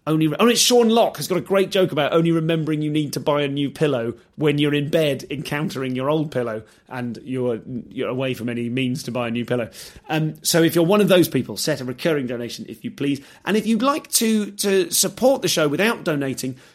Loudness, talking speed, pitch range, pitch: -20 LUFS, 240 wpm, 130-180 Hz, 150 Hz